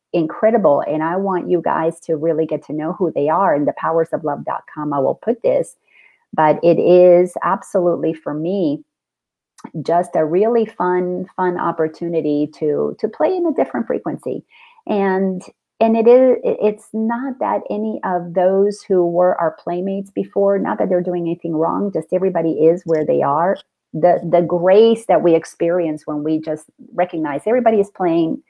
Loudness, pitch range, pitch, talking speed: -17 LUFS, 165-215 Hz, 180 Hz, 175 wpm